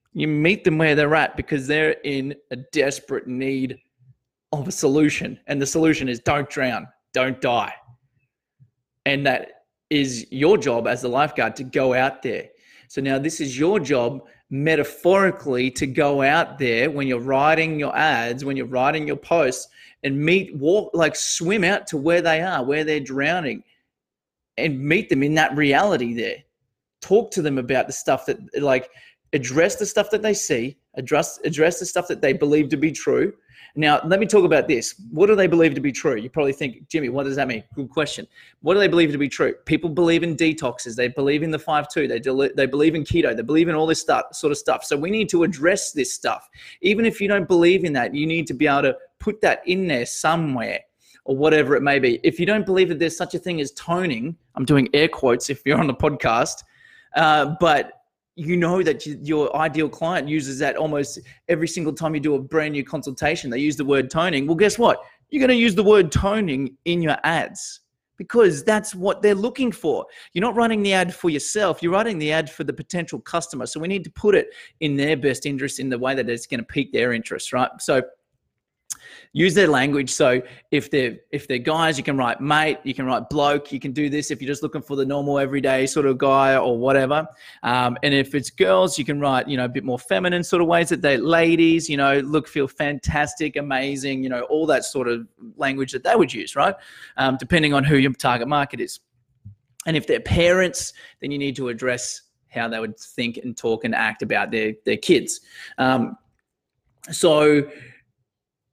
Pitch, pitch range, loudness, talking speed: 150 Hz, 135-170 Hz, -21 LUFS, 215 wpm